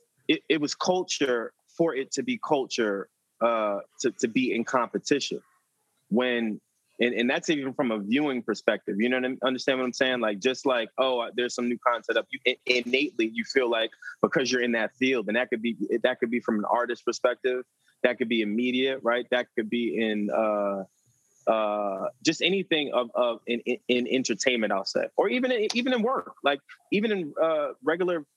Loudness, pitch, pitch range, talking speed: -27 LUFS, 125 Hz, 120-145 Hz, 205 wpm